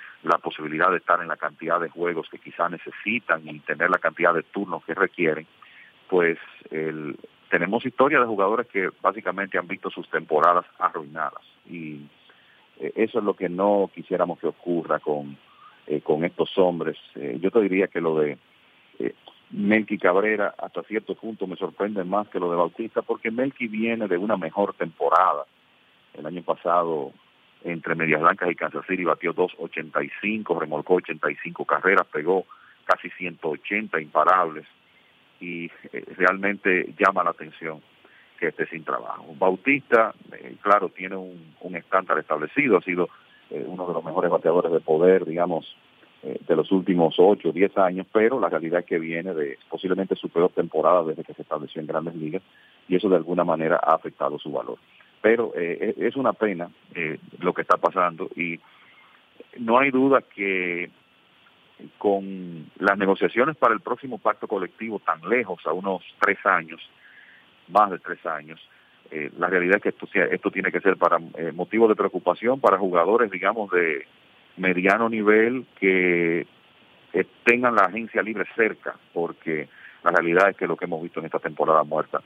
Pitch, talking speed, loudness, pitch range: 90 Hz, 170 wpm, -23 LUFS, 85-100 Hz